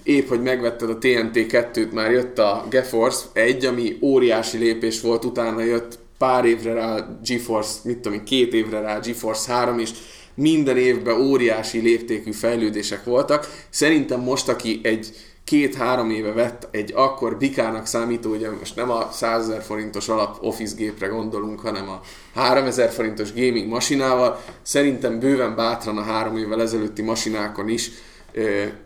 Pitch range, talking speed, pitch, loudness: 110-125 Hz, 150 wpm, 115 Hz, -21 LUFS